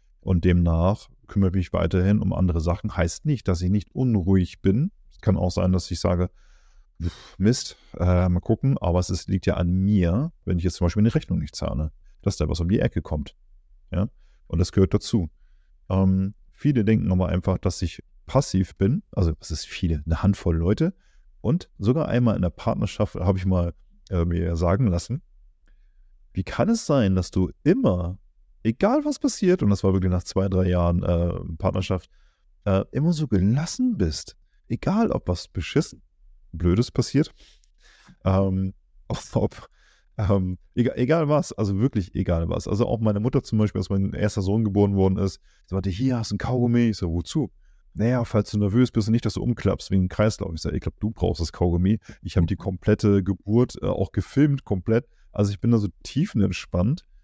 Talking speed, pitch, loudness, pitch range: 195 wpm, 95 Hz, -24 LUFS, 90-110 Hz